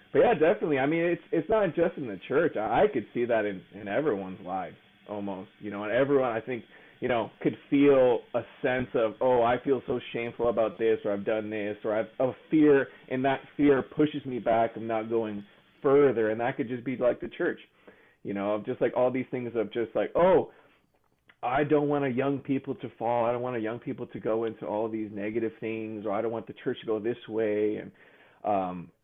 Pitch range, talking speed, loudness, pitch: 110-135 Hz, 235 wpm, -28 LUFS, 115 Hz